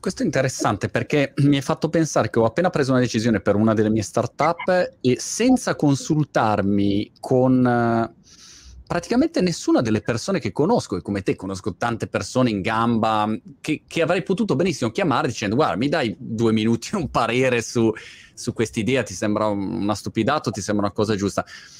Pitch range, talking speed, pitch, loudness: 110-150 Hz, 175 wpm, 120 Hz, -21 LUFS